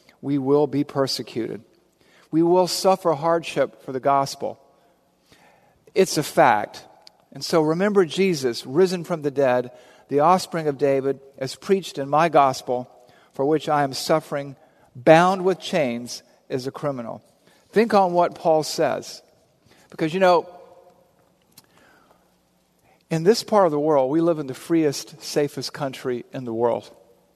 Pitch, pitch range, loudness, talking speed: 155 Hz, 135-175 Hz, -22 LUFS, 145 wpm